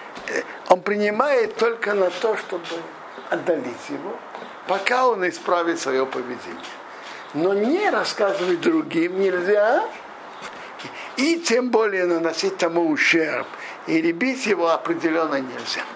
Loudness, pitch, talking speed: -22 LUFS, 205 Hz, 110 wpm